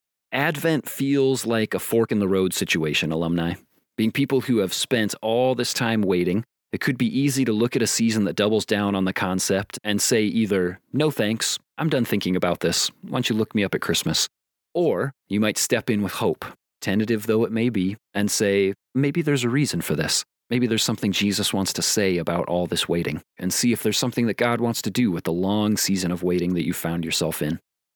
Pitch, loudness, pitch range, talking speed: 105 Hz, -23 LUFS, 95-120 Hz, 225 wpm